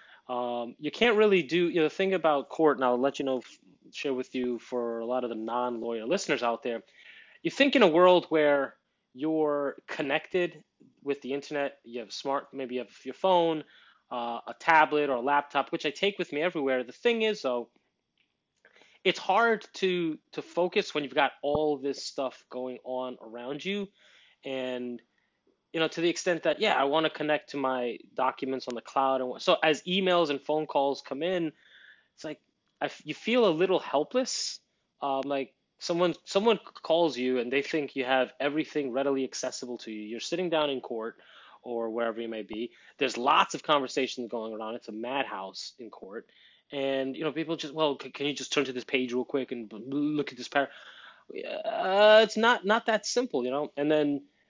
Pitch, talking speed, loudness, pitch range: 140 Hz, 200 wpm, -29 LUFS, 125-165 Hz